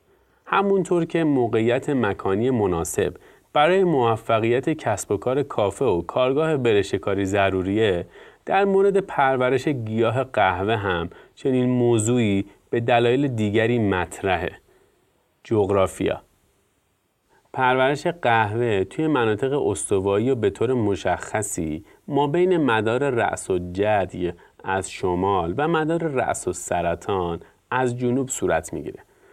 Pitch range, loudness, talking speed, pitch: 100-155 Hz, -22 LUFS, 110 wpm, 125 Hz